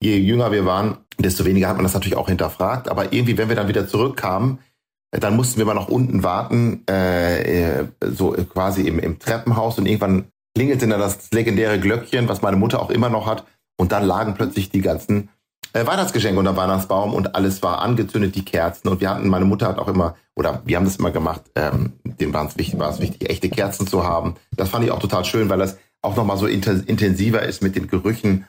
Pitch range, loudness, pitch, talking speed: 95-110 Hz, -20 LUFS, 100 Hz, 220 wpm